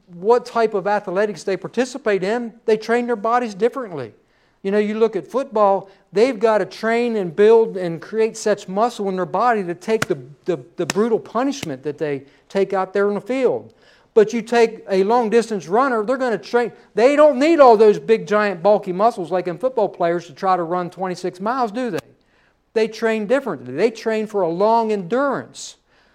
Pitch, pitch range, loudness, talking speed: 215 Hz, 190-235 Hz, -19 LUFS, 200 wpm